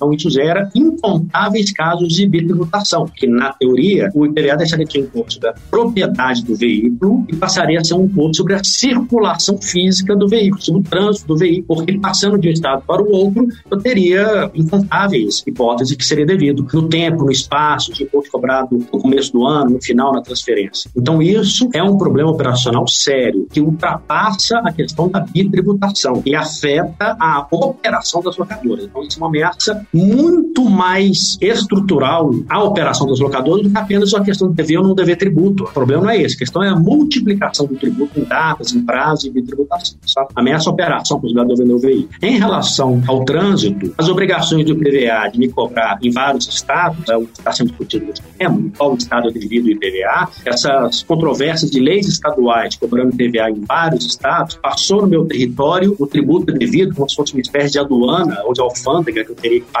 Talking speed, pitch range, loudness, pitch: 200 wpm, 135-195 Hz, -14 LUFS, 165 Hz